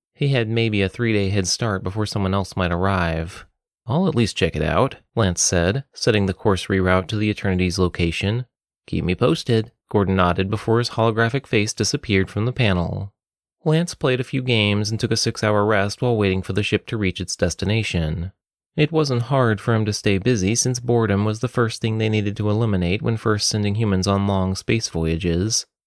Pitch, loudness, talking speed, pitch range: 105 Hz, -21 LUFS, 205 wpm, 95-115 Hz